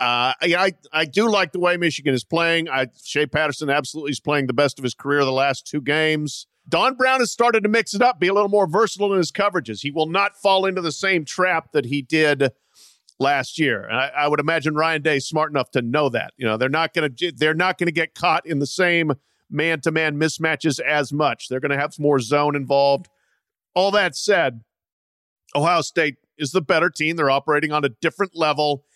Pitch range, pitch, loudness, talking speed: 145-180 Hz, 155 Hz, -20 LUFS, 230 wpm